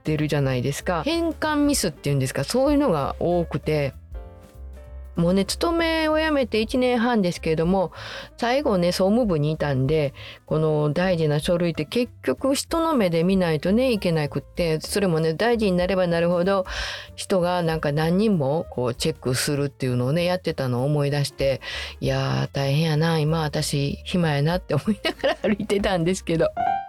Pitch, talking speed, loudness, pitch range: 170 Hz, 360 characters per minute, -23 LUFS, 145-210 Hz